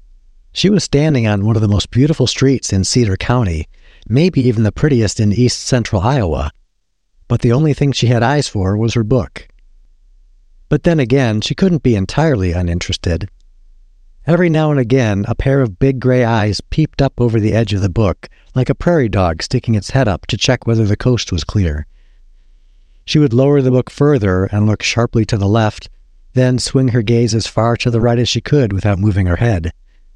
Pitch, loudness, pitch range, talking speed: 115 Hz, -14 LUFS, 90-130 Hz, 200 wpm